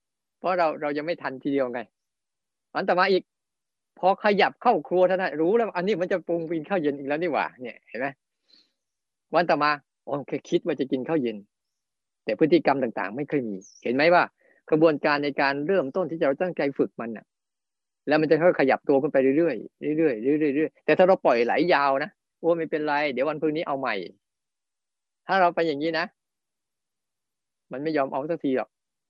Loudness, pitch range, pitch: -24 LUFS, 140-175 Hz, 155 Hz